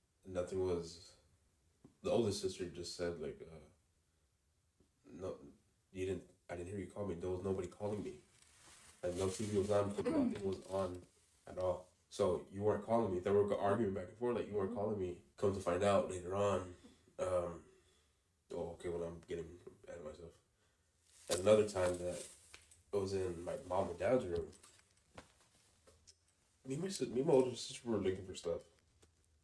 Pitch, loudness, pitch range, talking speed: 90 Hz, -39 LUFS, 85-100 Hz, 175 wpm